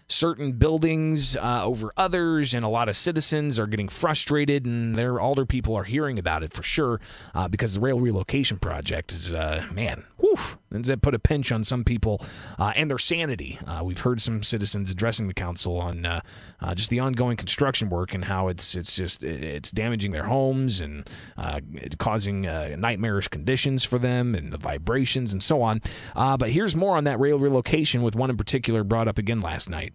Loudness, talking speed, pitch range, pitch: -24 LUFS, 200 wpm, 95-130 Hz, 115 Hz